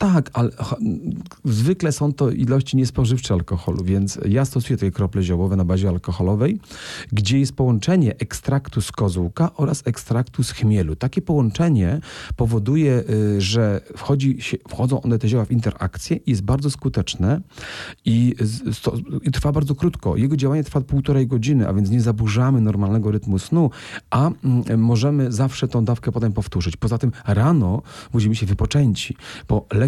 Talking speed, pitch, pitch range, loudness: 150 wpm, 120 Hz, 105-135 Hz, -20 LUFS